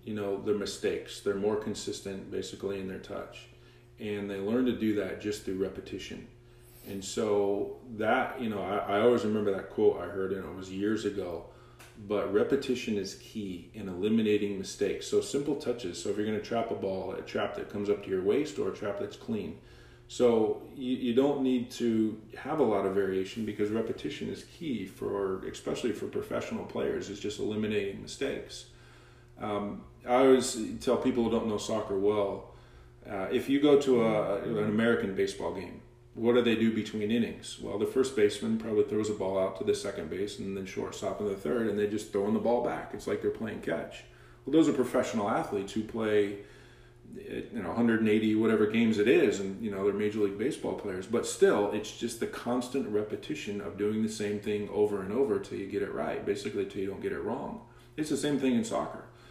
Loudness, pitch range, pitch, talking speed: -31 LUFS, 100-120 Hz, 105 Hz, 210 wpm